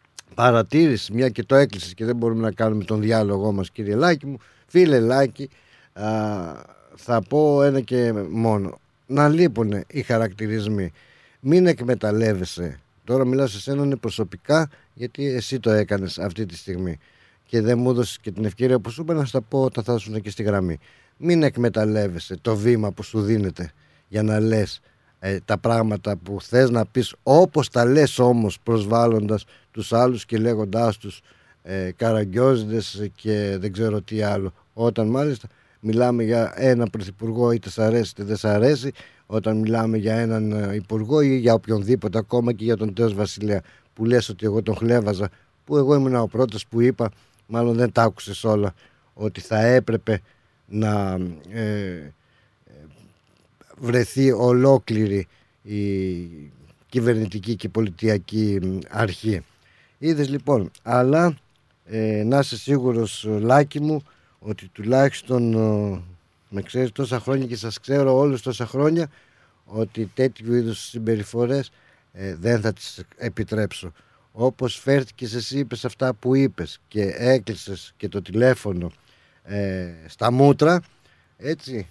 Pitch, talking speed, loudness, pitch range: 115 Hz, 145 wpm, -22 LUFS, 105-125 Hz